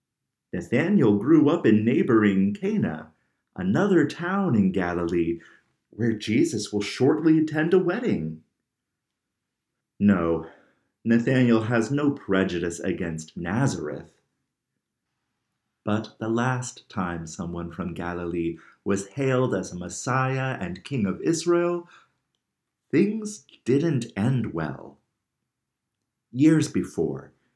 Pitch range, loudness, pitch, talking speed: 90-145 Hz, -24 LUFS, 110 Hz, 100 wpm